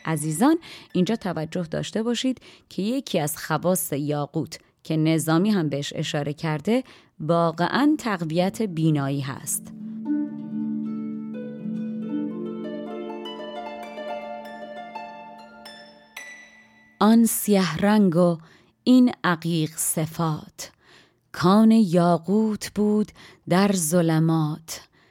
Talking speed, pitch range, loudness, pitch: 75 wpm, 145-210 Hz, -23 LUFS, 170 Hz